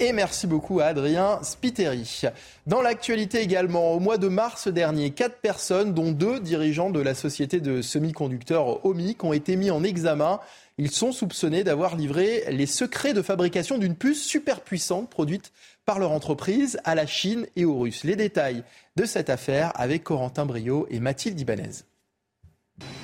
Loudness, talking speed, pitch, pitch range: -25 LUFS, 165 wpm, 180 Hz, 150-210 Hz